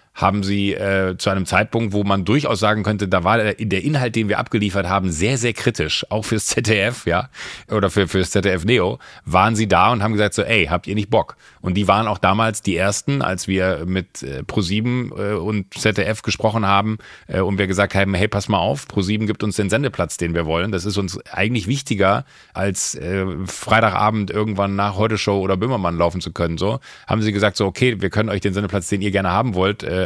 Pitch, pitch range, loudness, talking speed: 100 Hz, 95-110 Hz, -19 LUFS, 225 wpm